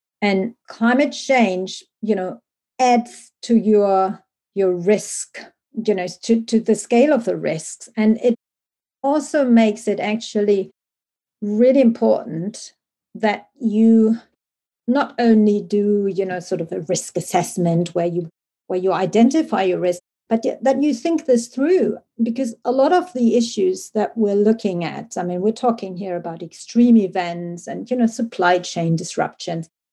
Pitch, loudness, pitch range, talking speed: 215 Hz, -19 LUFS, 185-240 Hz, 150 wpm